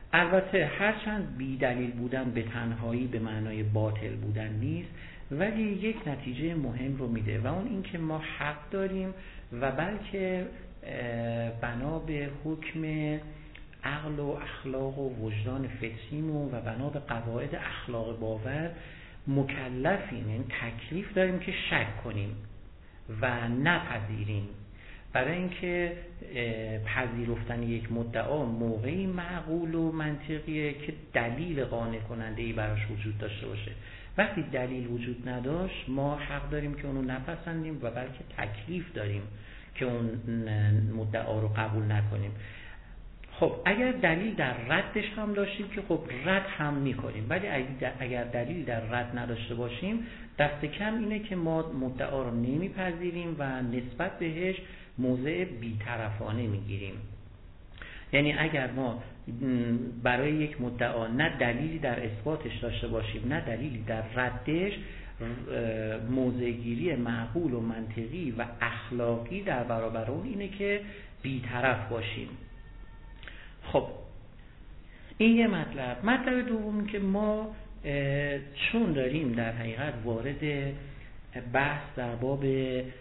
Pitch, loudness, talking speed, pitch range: 125 Hz, -32 LUFS, 120 wpm, 115-155 Hz